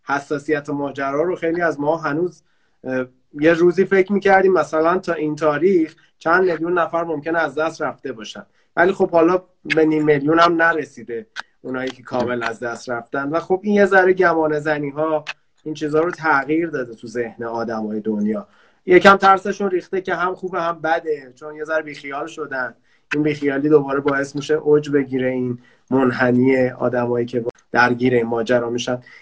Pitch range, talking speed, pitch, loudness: 130-170 Hz, 170 wpm, 150 Hz, -19 LUFS